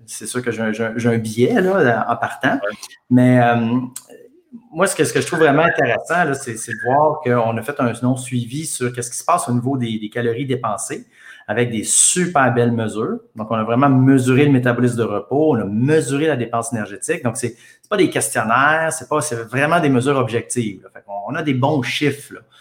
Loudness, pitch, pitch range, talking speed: -18 LUFS, 125 Hz, 115-145 Hz, 220 wpm